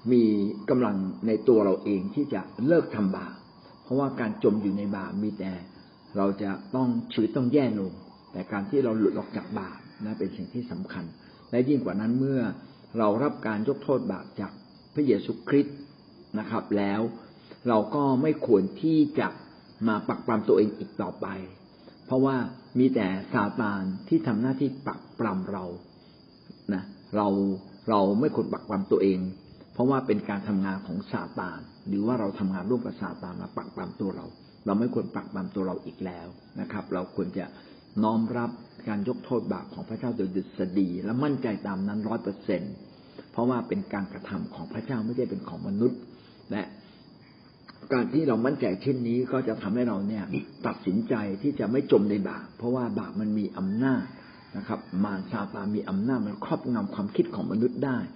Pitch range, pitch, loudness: 100-125 Hz, 105 Hz, -28 LUFS